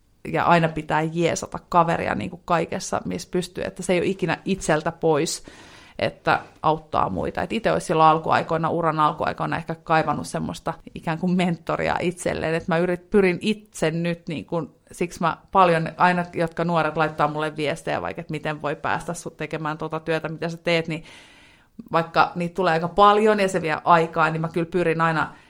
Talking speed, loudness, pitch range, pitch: 185 wpm, -23 LUFS, 155-175 Hz, 165 Hz